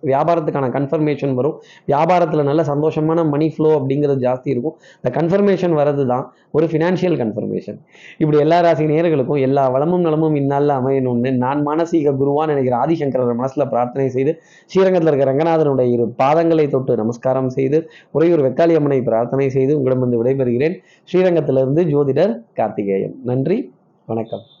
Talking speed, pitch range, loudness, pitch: 130 wpm, 130-160 Hz, -17 LUFS, 145 Hz